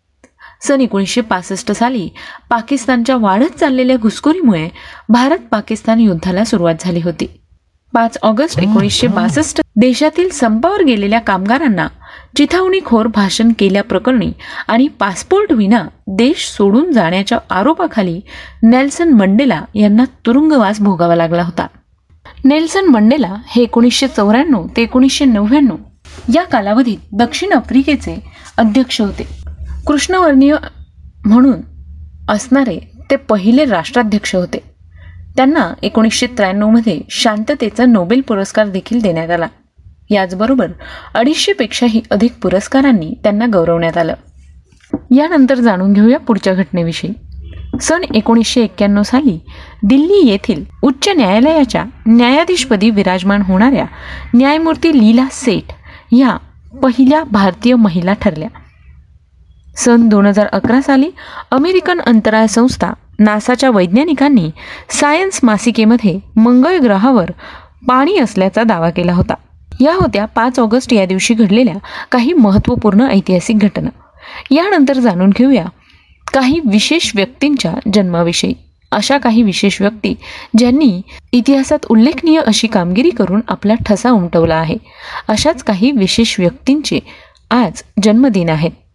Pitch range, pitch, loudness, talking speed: 200-265 Hz, 230 Hz, -12 LUFS, 105 wpm